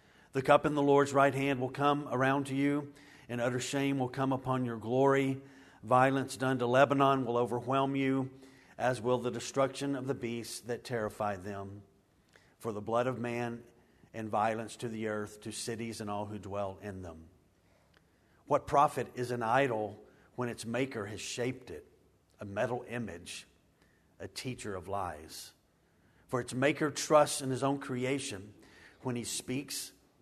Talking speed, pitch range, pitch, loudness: 165 wpm, 105-135 Hz, 120 Hz, -33 LUFS